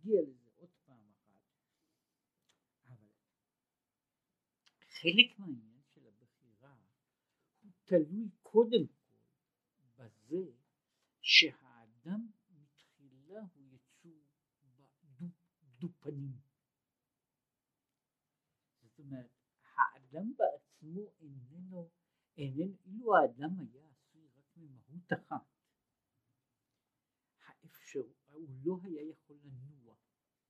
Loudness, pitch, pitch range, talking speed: -33 LUFS, 150 Hz, 130-175 Hz, 75 wpm